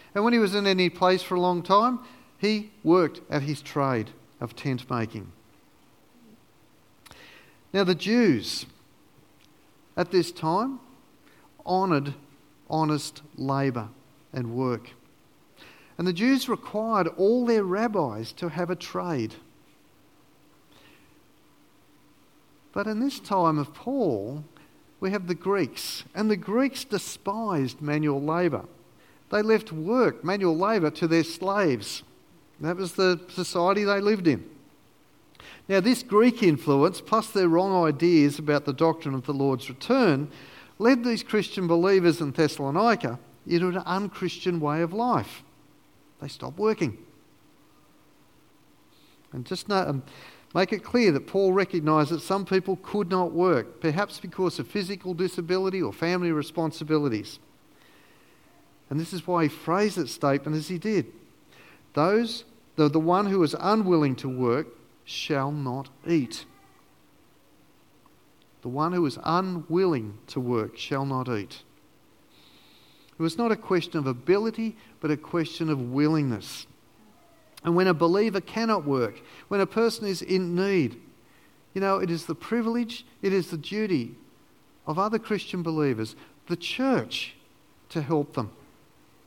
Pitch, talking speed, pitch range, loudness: 170 Hz, 135 wpm, 145-195 Hz, -26 LUFS